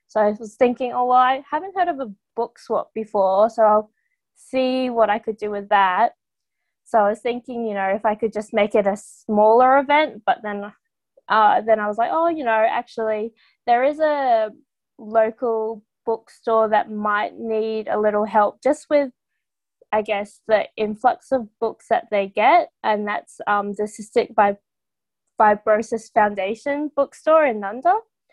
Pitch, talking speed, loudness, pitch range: 220 Hz, 170 wpm, -20 LUFS, 210-255 Hz